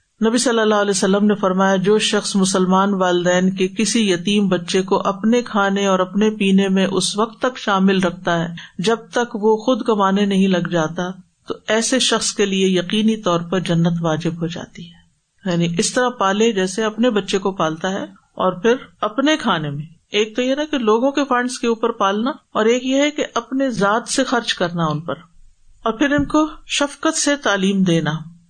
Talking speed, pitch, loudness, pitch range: 200 wpm, 205 Hz, -18 LUFS, 185-230 Hz